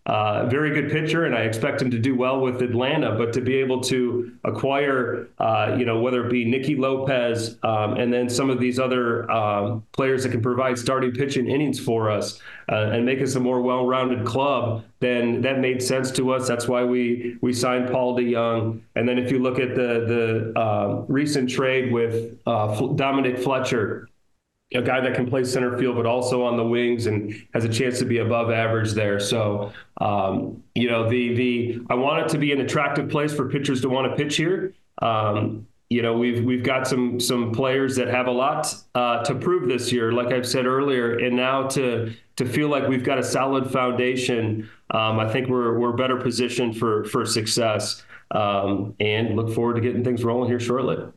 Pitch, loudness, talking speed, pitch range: 125 Hz, -23 LUFS, 205 wpm, 115-130 Hz